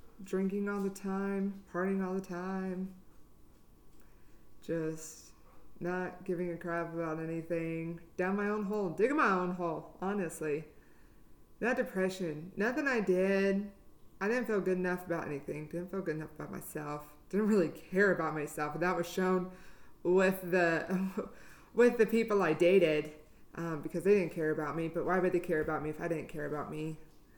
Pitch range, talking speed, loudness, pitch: 160-195 Hz, 170 wpm, -33 LUFS, 180 Hz